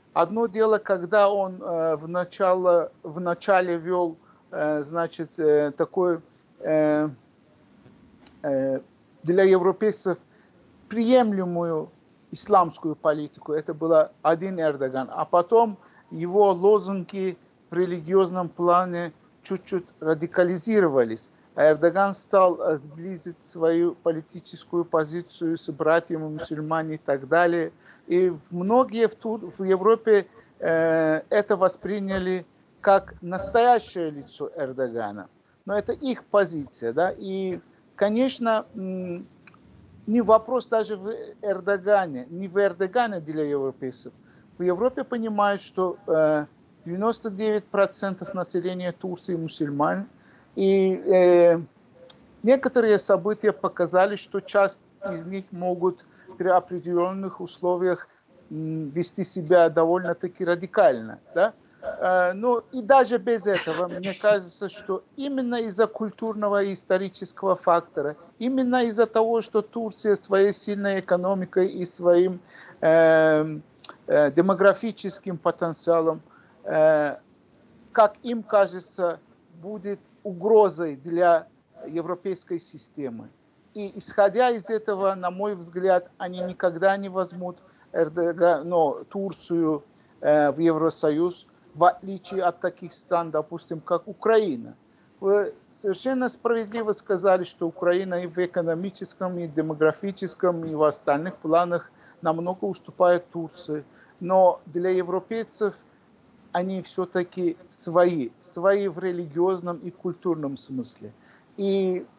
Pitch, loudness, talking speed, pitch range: 180 Hz, -24 LUFS, 105 wpm, 170-200 Hz